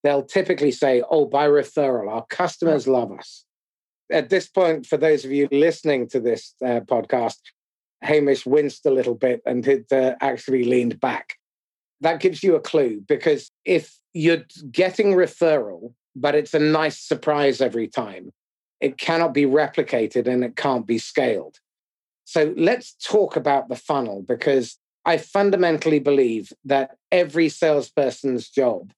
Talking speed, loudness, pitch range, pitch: 150 wpm, -21 LUFS, 130-165 Hz, 145 Hz